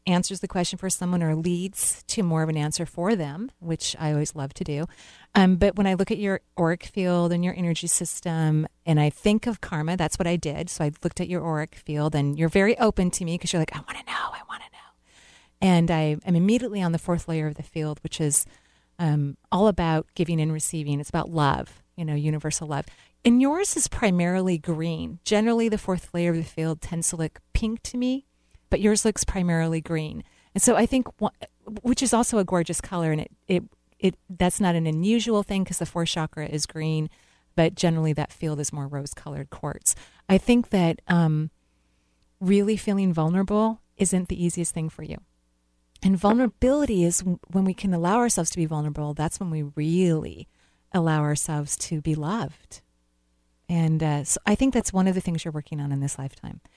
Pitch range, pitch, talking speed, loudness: 155-190 Hz, 170 Hz, 210 wpm, -25 LUFS